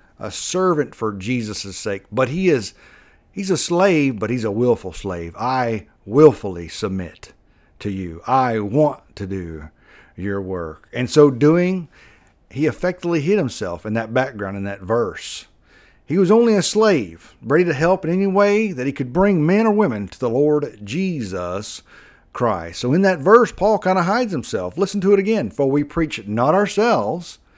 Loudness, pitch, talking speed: -19 LUFS, 135 Hz, 175 wpm